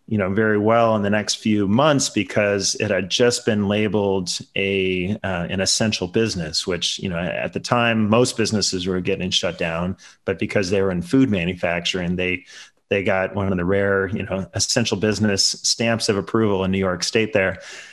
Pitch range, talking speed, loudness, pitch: 95-110 Hz, 195 wpm, -20 LUFS, 100 Hz